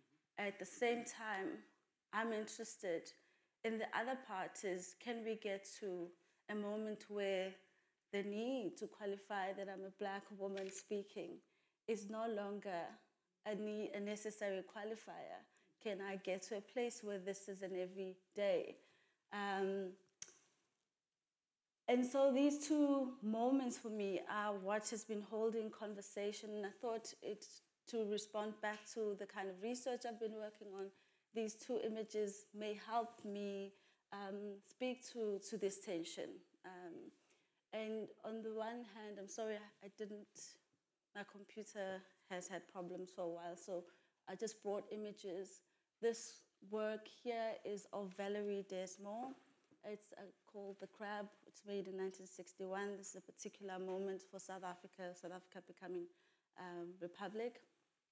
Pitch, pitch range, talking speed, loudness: 205 Hz, 195-220 Hz, 145 wpm, -46 LUFS